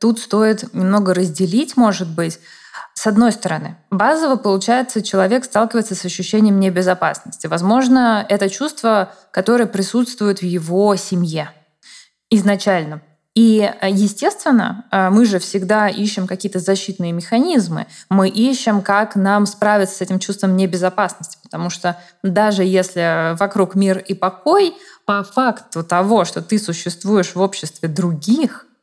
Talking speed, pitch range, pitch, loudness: 125 wpm, 185-225 Hz, 200 Hz, -17 LUFS